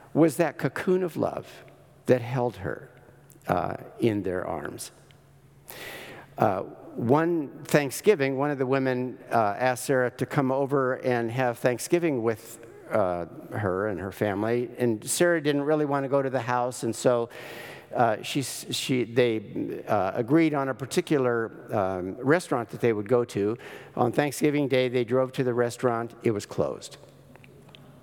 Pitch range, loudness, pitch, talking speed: 120-145 Hz, -26 LUFS, 125 Hz, 155 wpm